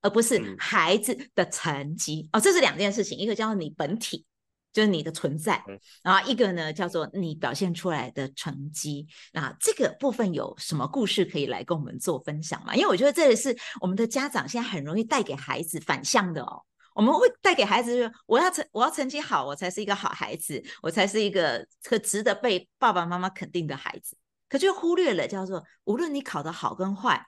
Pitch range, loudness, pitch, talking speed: 165-235 Hz, -26 LUFS, 195 Hz, 320 characters per minute